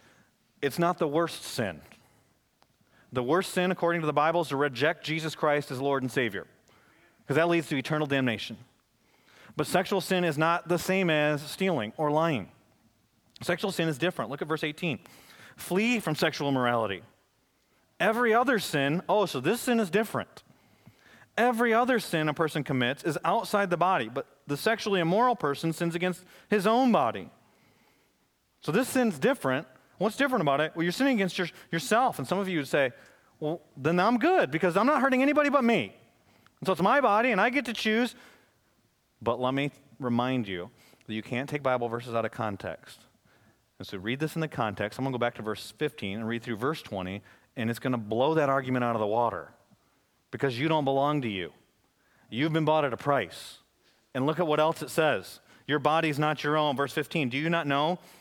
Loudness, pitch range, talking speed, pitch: -28 LUFS, 130-180 Hz, 200 wpm, 155 Hz